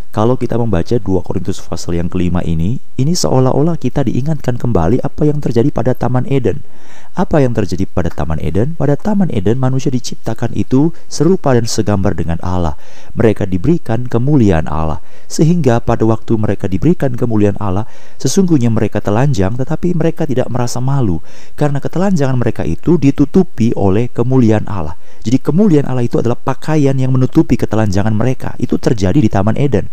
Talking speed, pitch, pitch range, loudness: 160 wpm, 120 Hz, 100-140 Hz, -14 LUFS